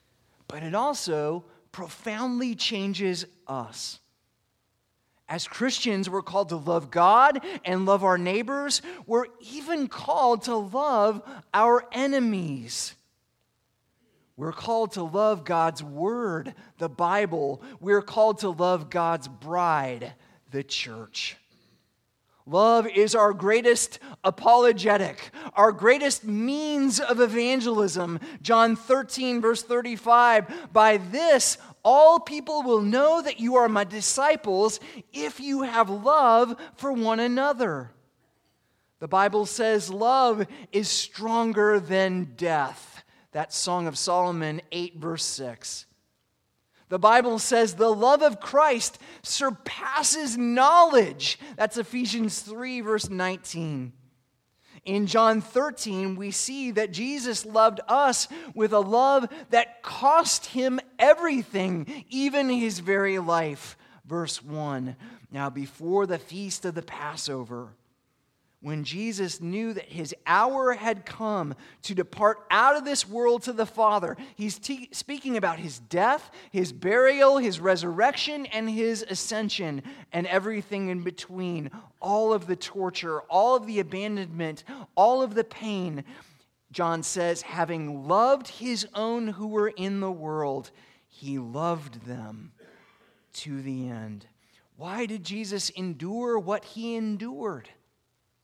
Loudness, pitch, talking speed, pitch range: -25 LUFS, 205 Hz, 120 wpm, 165-240 Hz